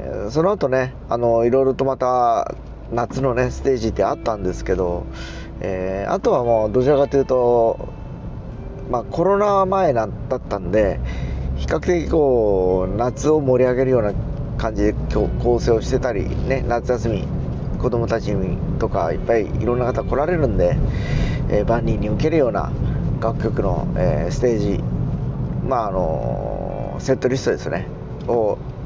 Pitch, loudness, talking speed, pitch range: 120 Hz, -20 LUFS, 290 characters per minute, 105-135 Hz